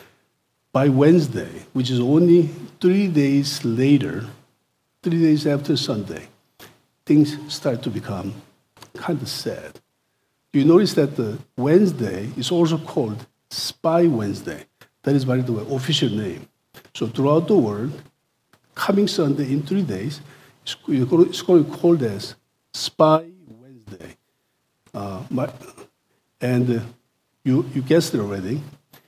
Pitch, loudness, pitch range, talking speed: 140 Hz, -20 LUFS, 125-160 Hz, 125 wpm